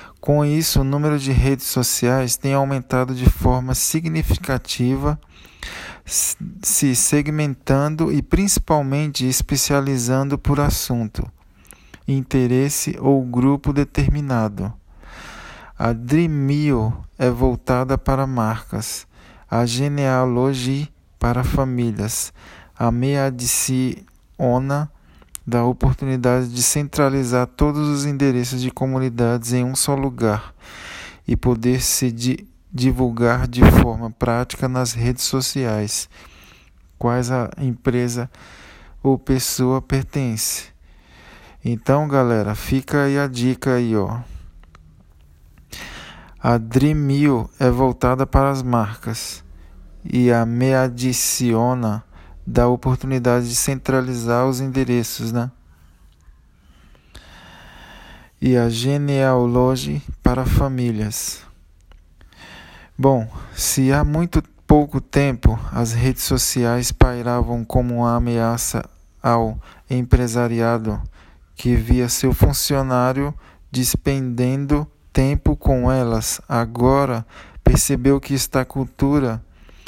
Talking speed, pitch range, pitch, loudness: 95 wpm, 115-135 Hz, 125 Hz, -19 LUFS